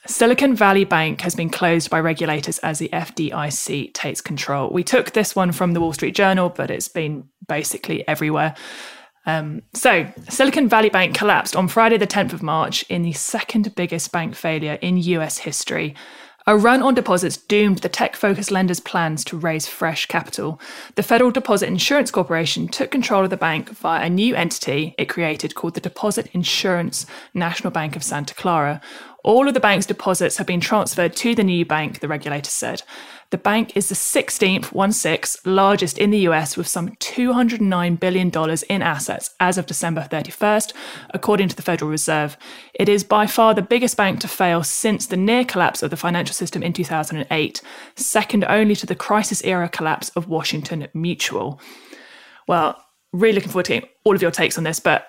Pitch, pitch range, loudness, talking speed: 185 Hz, 165-210 Hz, -19 LUFS, 185 wpm